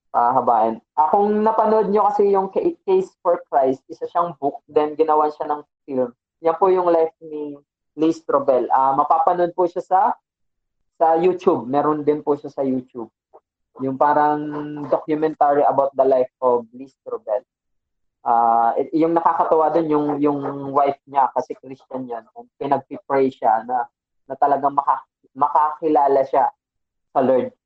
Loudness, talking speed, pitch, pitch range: -19 LUFS, 155 wpm, 150 Hz, 135-170 Hz